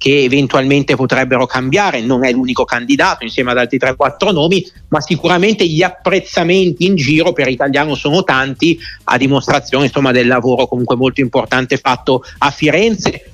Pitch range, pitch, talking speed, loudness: 130-175 Hz, 140 Hz, 155 wpm, -13 LUFS